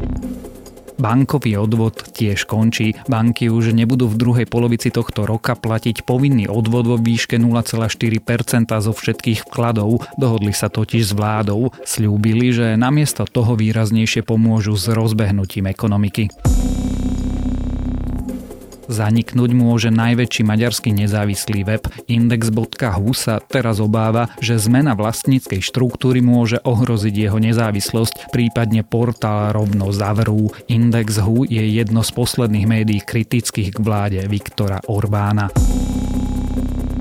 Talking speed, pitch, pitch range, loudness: 110 wpm, 115 Hz, 105-120 Hz, -17 LUFS